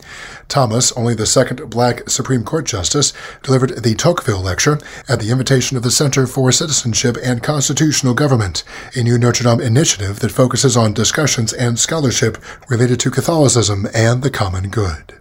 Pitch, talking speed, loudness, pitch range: 125 Hz, 160 wpm, -15 LUFS, 115-135 Hz